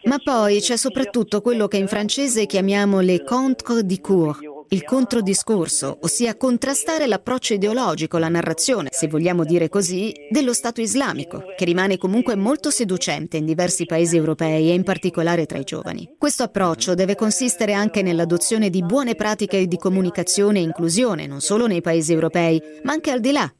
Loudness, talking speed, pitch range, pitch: -20 LUFS, 165 wpm, 170-235 Hz, 200 Hz